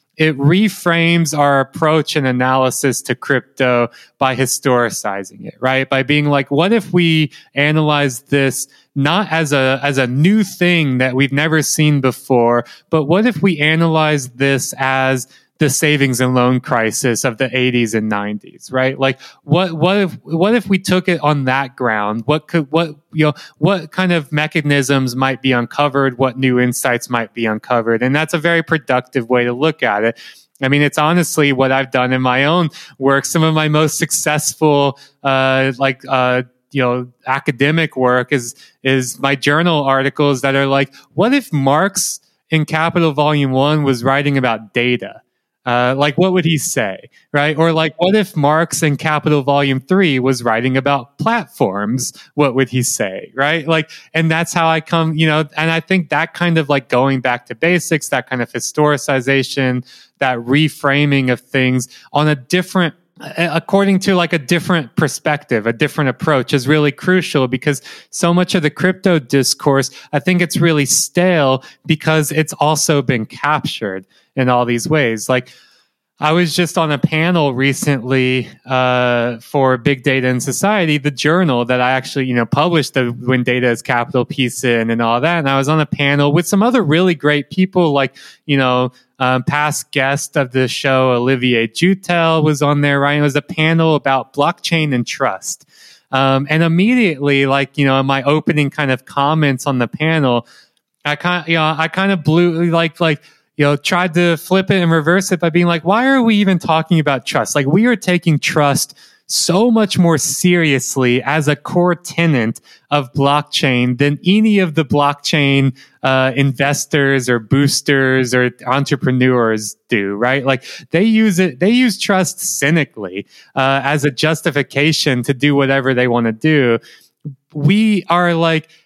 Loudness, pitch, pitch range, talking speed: -15 LUFS, 145 Hz, 130-165 Hz, 175 wpm